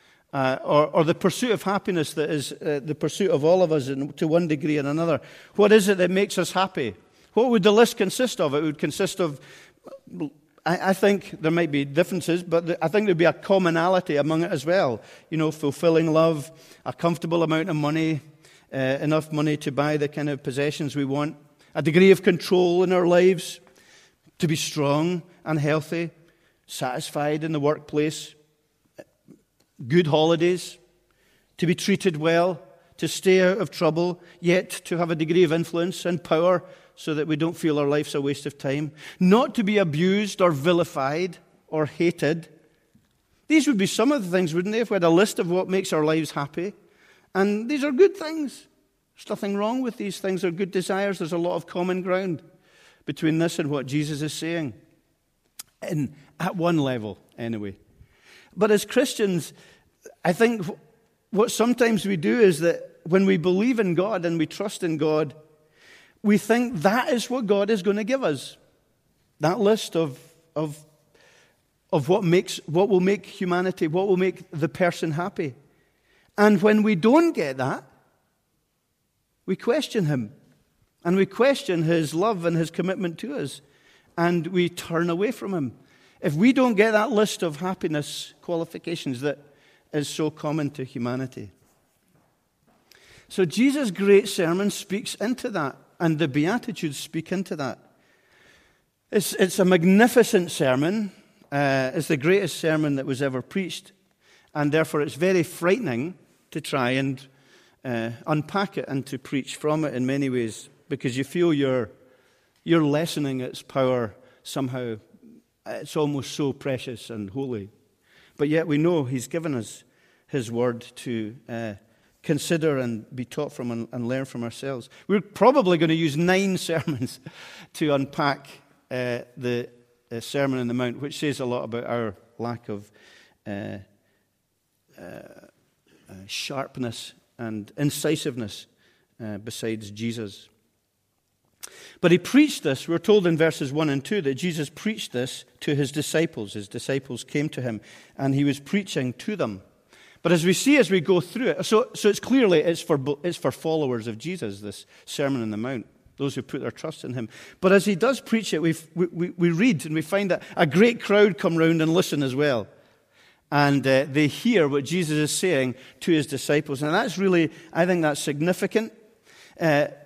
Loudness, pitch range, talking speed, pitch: -24 LUFS, 140-185 Hz, 175 wpm, 160 Hz